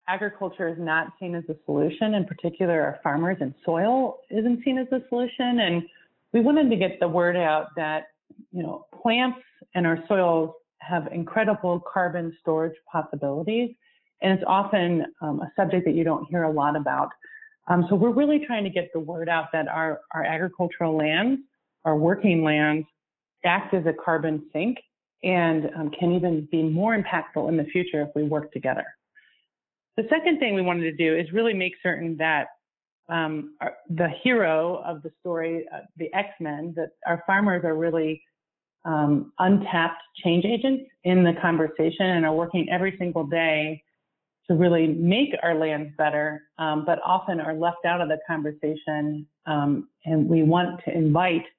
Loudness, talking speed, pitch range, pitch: -24 LUFS, 175 wpm, 160-190 Hz, 170 Hz